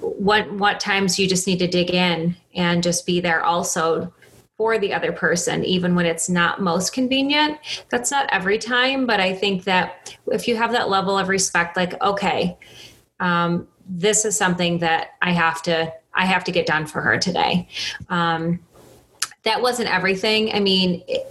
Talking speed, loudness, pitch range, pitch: 180 wpm, -20 LUFS, 175-210 Hz, 185 Hz